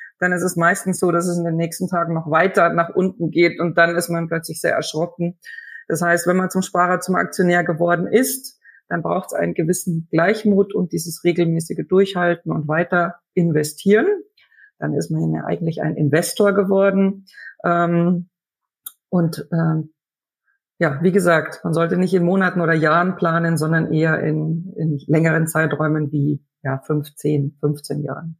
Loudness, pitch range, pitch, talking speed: -19 LUFS, 160-185 Hz, 170 Hz, 165 wpm